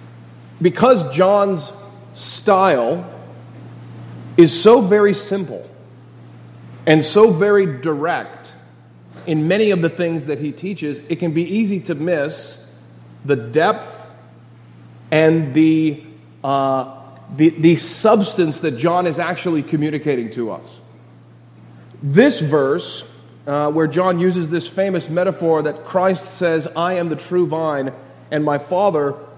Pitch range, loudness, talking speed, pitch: 110-180 Hz, -17 LUFS, 125 wpm, 155 Hz